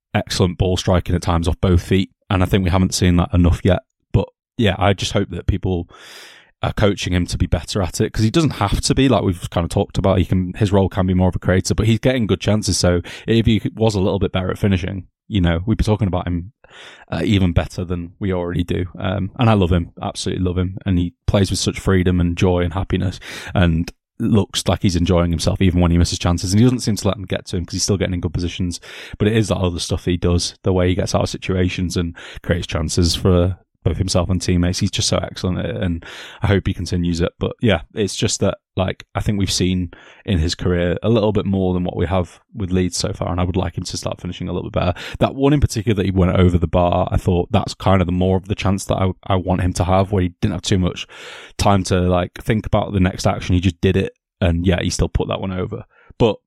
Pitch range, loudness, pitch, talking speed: 90-100 Hz, -19 LUFS, 95 Hz, 270 wpm